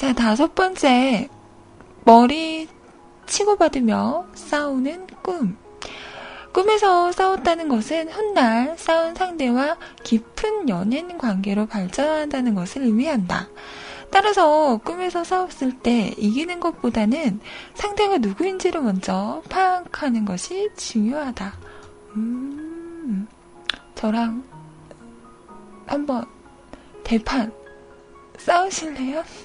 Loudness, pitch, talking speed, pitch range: -21 LUFS, 275 Hz, 200 characters per minute, 225-340 Hz